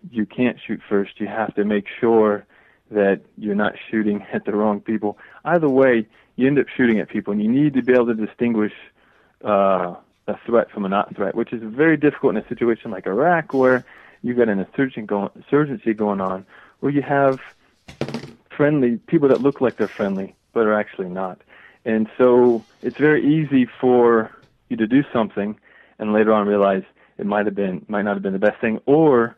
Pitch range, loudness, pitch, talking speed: 105-130 Hz, -20 LUFS, 110 Hz, 195 wpm